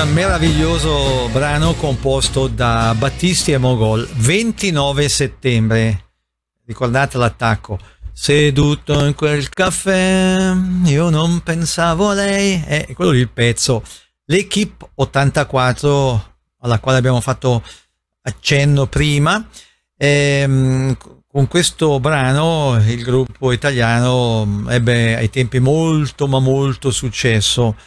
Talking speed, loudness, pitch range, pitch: 105 wpm, -15 LUFS, 120-155 Hz, 135 Hz